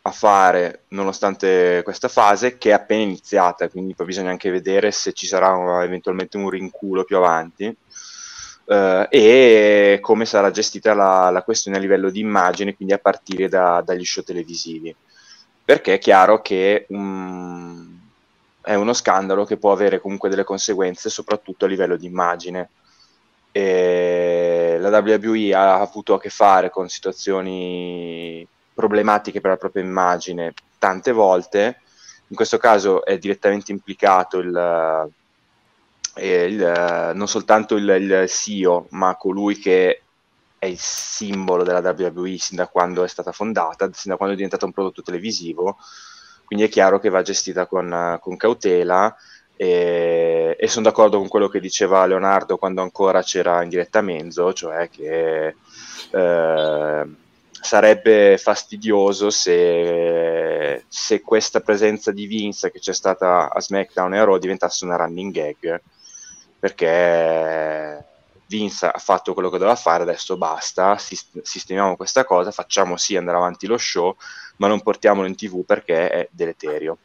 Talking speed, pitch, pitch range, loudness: 145 wpm, 95 Hz, 90-105 Hz, -18 LUFS